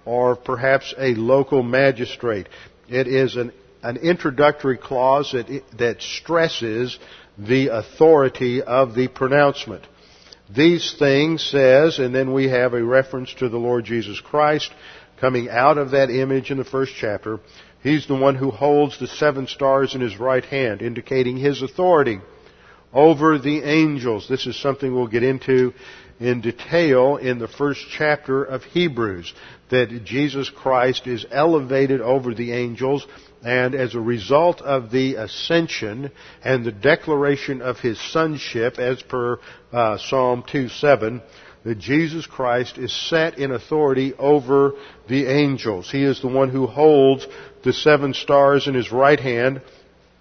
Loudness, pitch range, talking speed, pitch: -19 LUFS, 125-140 Hz, 145 wpm, 130 Hz